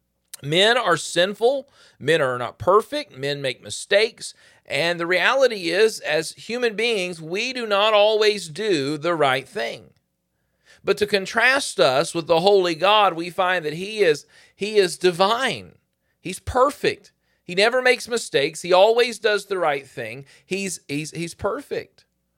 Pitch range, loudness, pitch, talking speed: 155-225 Hz, -21 LUFS, 190 Hz, 155 wpm